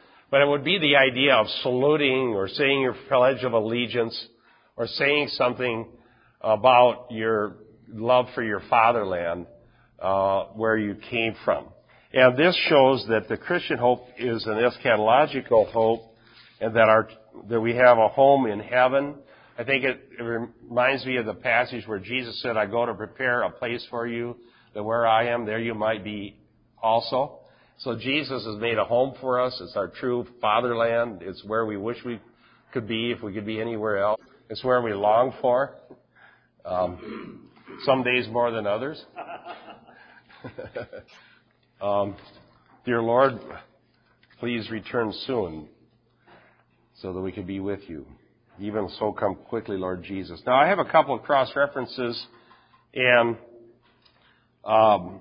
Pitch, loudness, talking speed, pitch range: 115 Hz, -23 LUFS, 155 wpm, 110-125 Hz